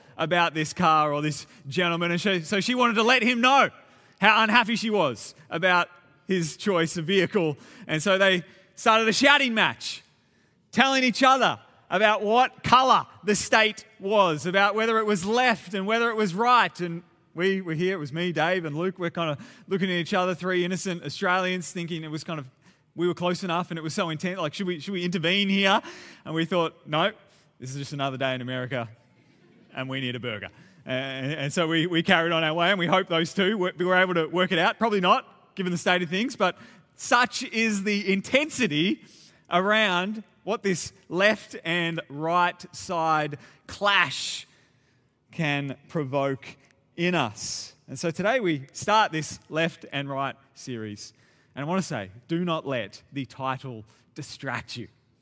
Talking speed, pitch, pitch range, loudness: 185 wpm, 175 Hz, 145-200 Hz, -24 LUFS